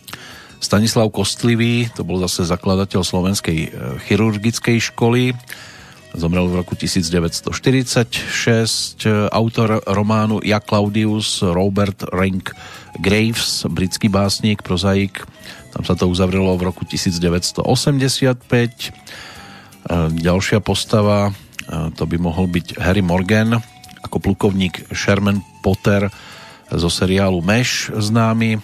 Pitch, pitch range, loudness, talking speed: 100 Hz, 90-110 Hz, -17 LUFS, 95 wpm